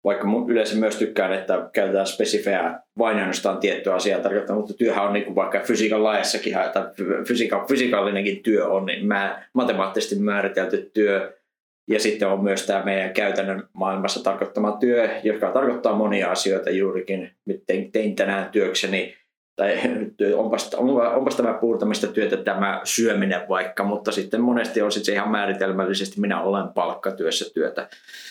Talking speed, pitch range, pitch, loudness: 145 wpm, 95-110 Hz, 100 Hz, -22 LUFS